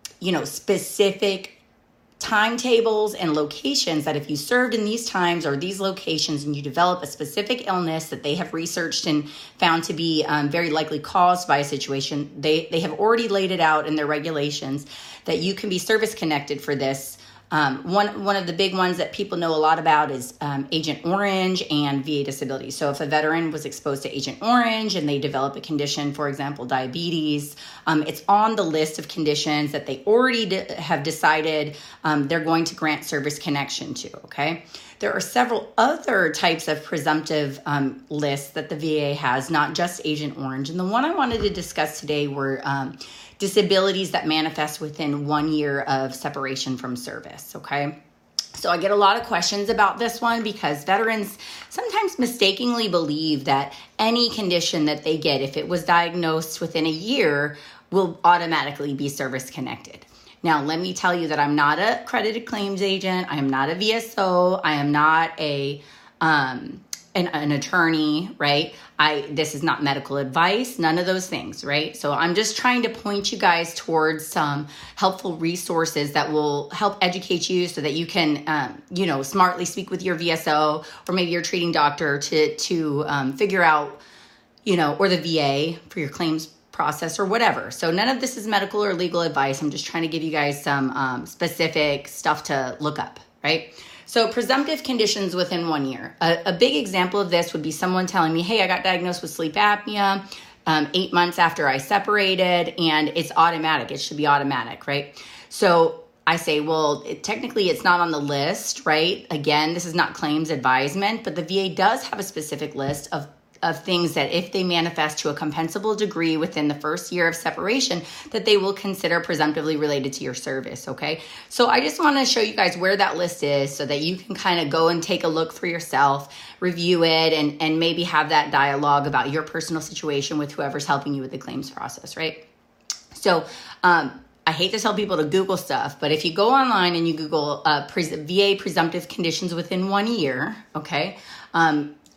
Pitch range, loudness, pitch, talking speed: 150-185 Hz, -22 LUFS, 160 Hz, 195 wpm